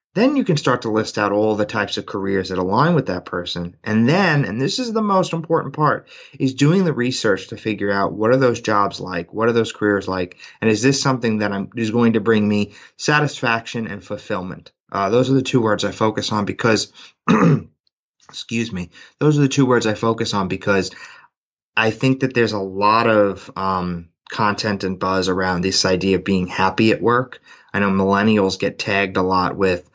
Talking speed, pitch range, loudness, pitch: 210 wpm, 95-125 Hz, -19 LUFS, 105 Hz